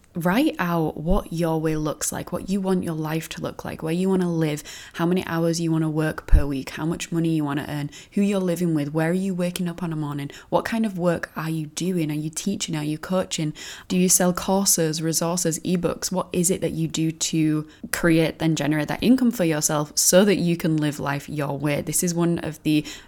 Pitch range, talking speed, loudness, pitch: 155-180 Hz, 245 wpm, -23 LUFS, 165 Hz